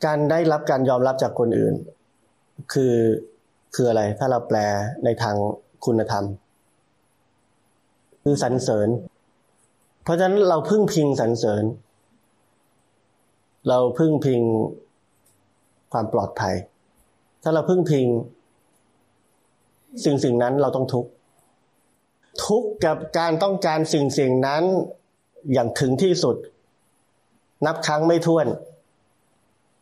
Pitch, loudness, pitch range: 135 Hz, -22 LUFS, 115-160 Hz